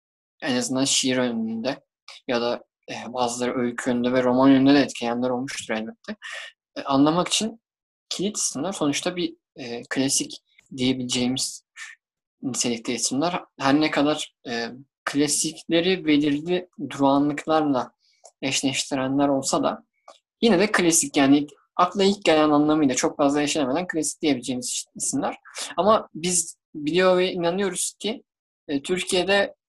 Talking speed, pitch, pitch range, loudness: 115 wpm, 145 Hz, 130-180 Hz, -23 LUFS